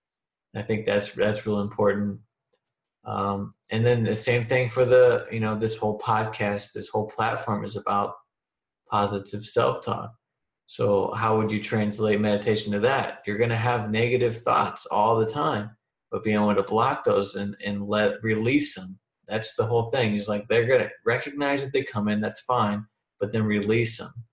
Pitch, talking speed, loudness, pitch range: 110 Hz, 180 wpm, -25 LUFS, 105-115 Hz